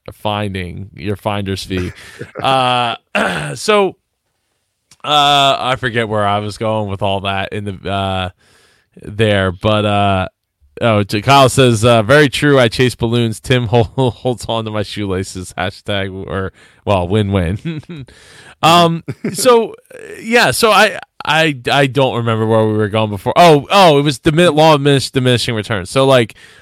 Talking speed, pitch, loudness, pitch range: 155 wpm, 115 Hz, -14 LUFS, 100-140 Hz